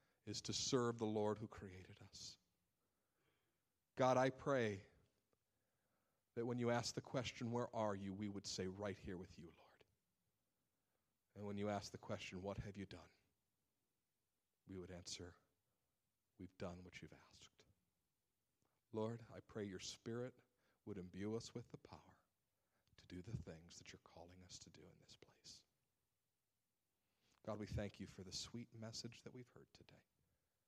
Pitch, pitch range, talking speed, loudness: 105 Hz, 95-115 Hz, 160 wpm, -47 LUFS